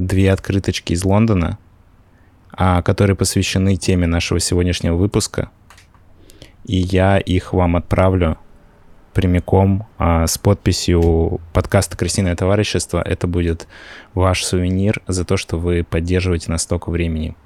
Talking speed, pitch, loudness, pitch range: 120 wpm, 90 Hz, -17 LUFS, 85-95 Hz